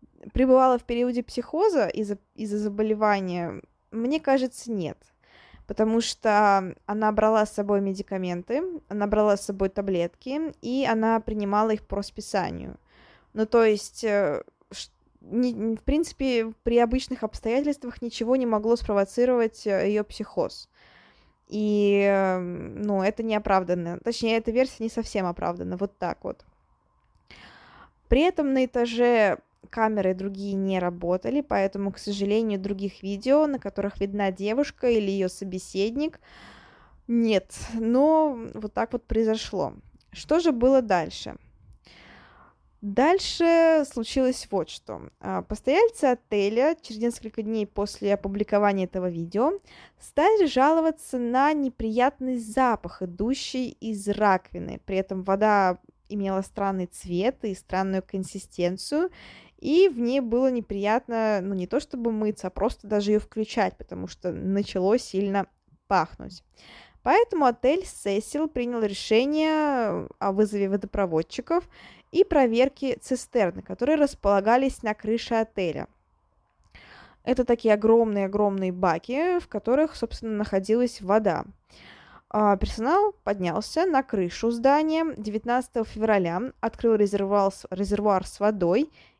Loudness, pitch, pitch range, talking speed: -25 LUFS, 220 Hz, 200-255 Hz, 115 wpm